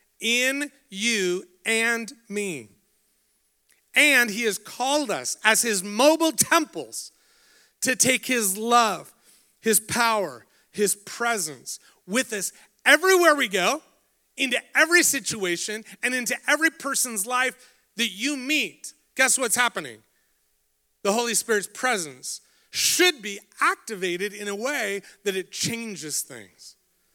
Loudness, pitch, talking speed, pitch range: -23 LUFS, 230 Hz, 120 wpm, 200-260 Hz